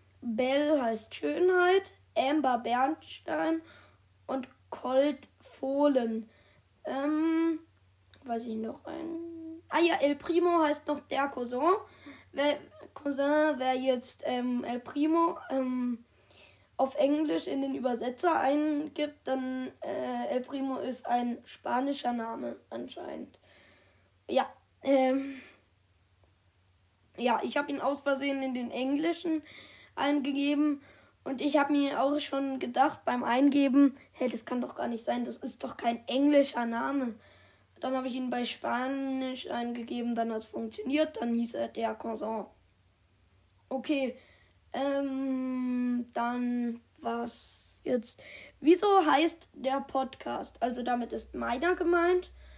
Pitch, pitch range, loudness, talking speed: 260 Hz, 235-290 Hz, -31 LUFS, 125 wpm